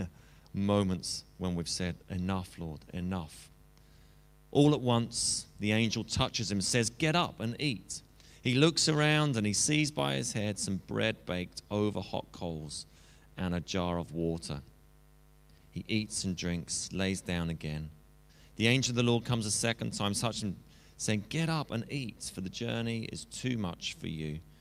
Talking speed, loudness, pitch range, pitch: 170 wpm, -32 LUFS, 85-115 Hz, 100 Hz